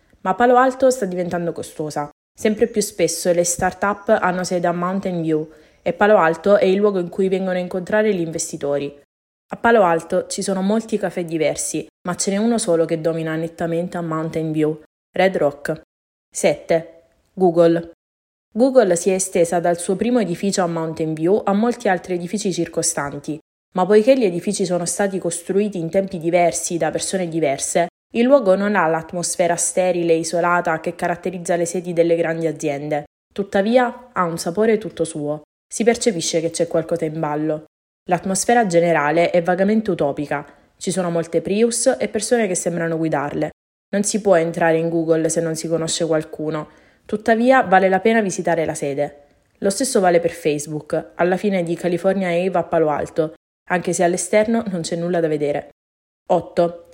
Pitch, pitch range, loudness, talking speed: 175 Hz, 165-195 Hz, -19 LUFS, 170 wpm